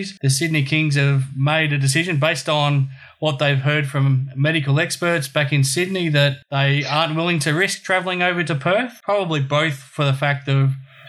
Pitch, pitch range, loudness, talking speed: 150 Hz, 140-165 Hz, -19 LUFS, 185 wpm